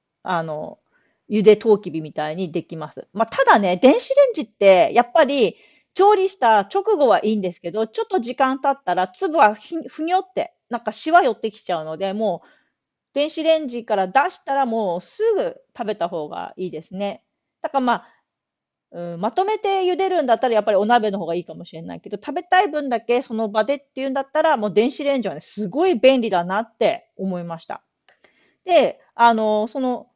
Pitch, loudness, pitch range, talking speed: 235 Hz, -20 LUFS, 200-300 Hz, 380 characters per minute